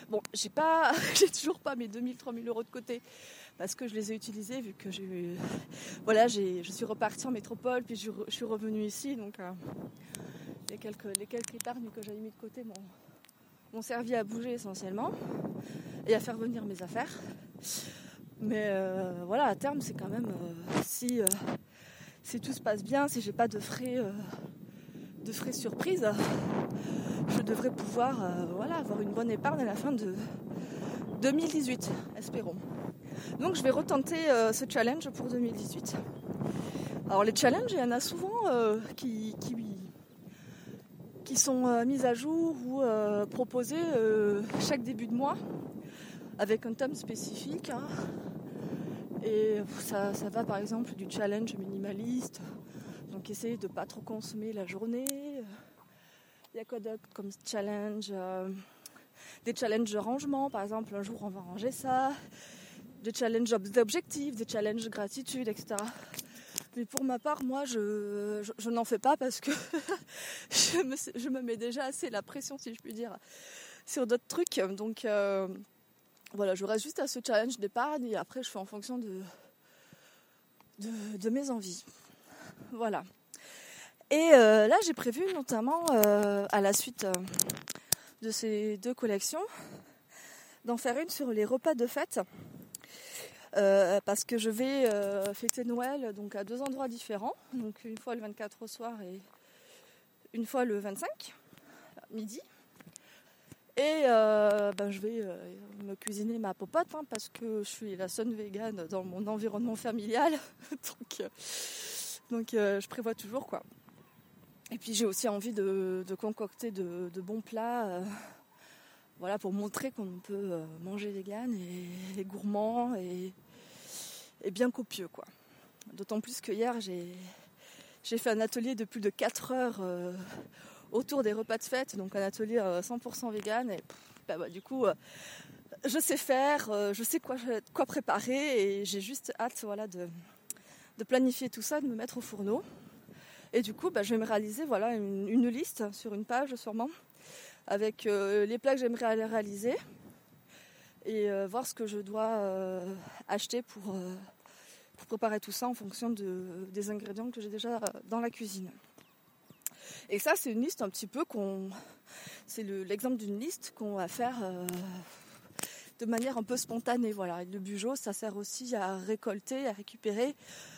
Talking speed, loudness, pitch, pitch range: 170 wpm, -34 LUFS, 220 Hz, 205-250 Hz